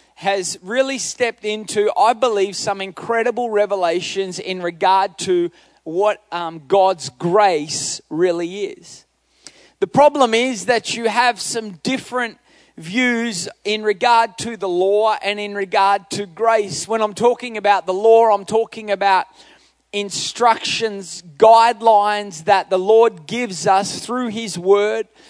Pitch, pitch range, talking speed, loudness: 210 Hz, 195-230 Hz, 135 wpm, -18 LUFS